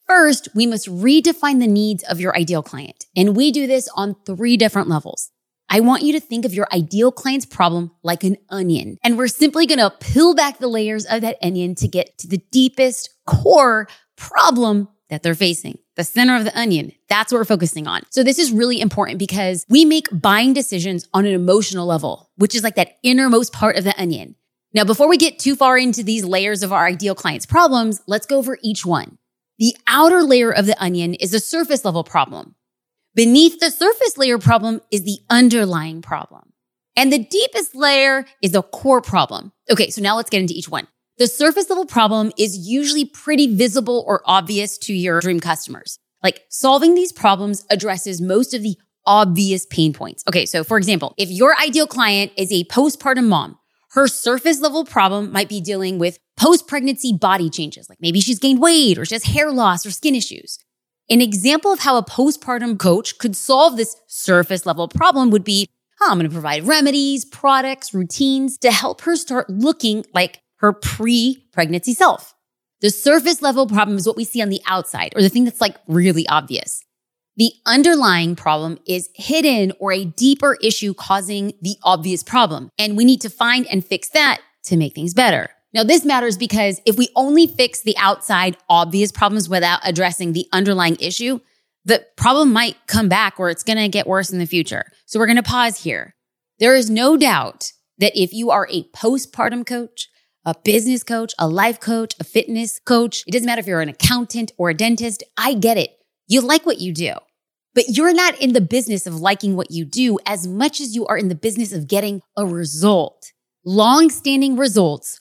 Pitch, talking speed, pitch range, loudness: 215 Hz, 195 wpm, 185-255 Hz, -16 LUFS